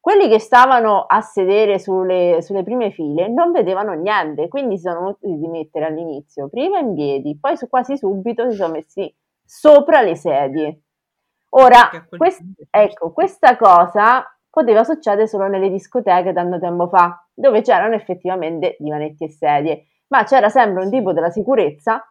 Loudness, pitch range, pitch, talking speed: -15 LUFS, 170-245 Hz, 195 Hz, 155 wpm